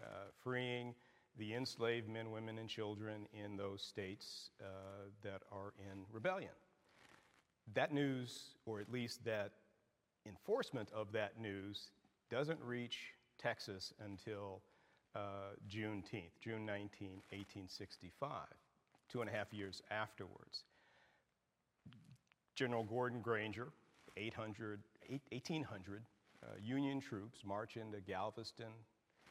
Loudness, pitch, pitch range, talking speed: -47 LUFS, 110 Hz, 100-120 Hz, 105 wpm